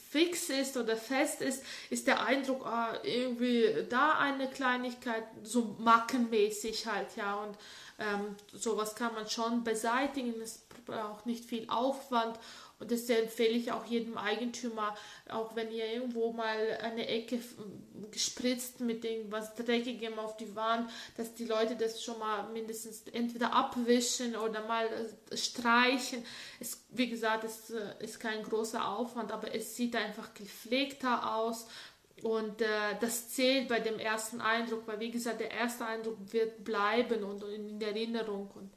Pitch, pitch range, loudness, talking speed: 230 Hz, 220-240 Hz, -34 LUFS, 150 wpm